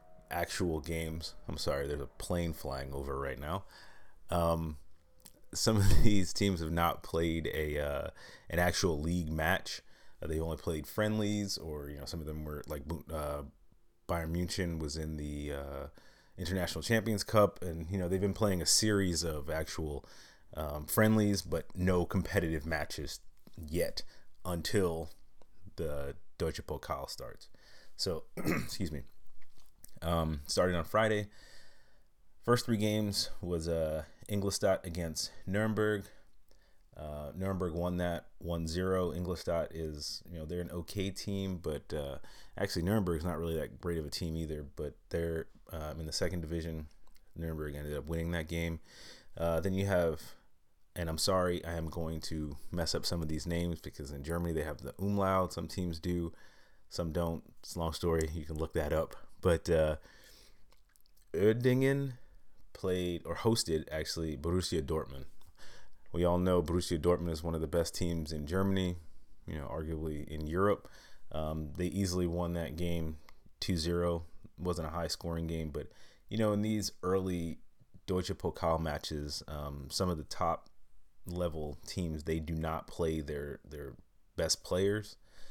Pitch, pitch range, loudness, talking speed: 85 Hz, 80-95 Hz, -35 LUFS, 160 wpm